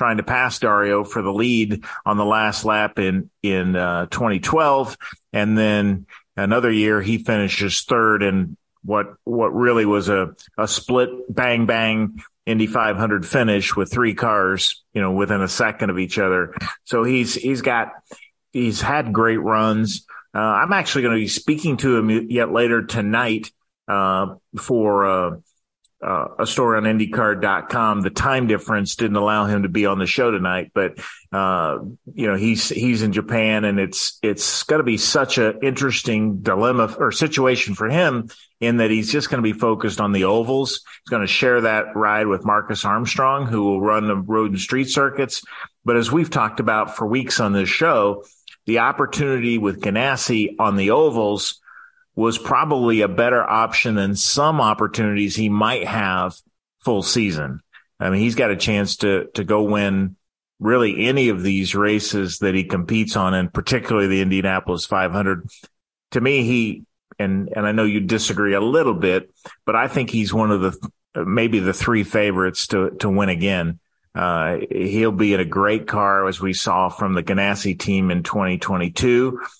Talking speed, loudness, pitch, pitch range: 175 wpm, -19 LUFS, 110 Hz, 100-115 Hz